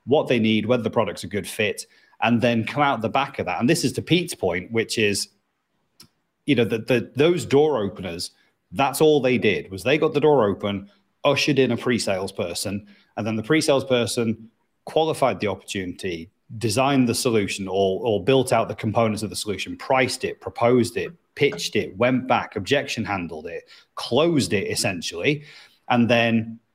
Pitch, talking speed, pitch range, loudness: 120 Hz, 185 wpm, 110-140 Hz, -22 LUFS